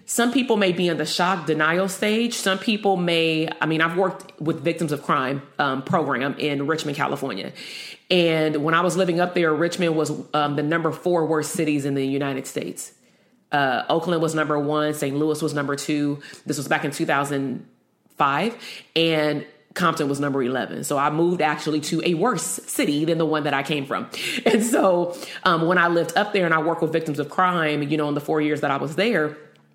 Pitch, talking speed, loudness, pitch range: 160 Hz, 210 wpm, -22 LUFS, 150-175 Hz